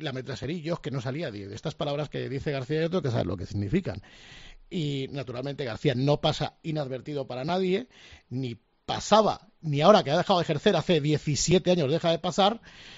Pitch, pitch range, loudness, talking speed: 150 Hz, 135-175 Hz, -27 LUFS, 180 wpm